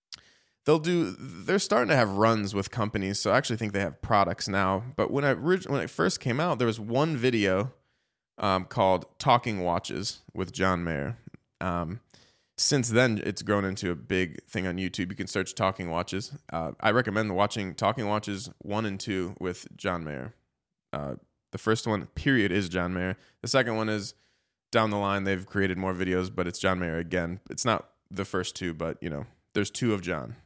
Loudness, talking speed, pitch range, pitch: -28 LUFS, 195 wpm, 90-115 Hz, 100 Hz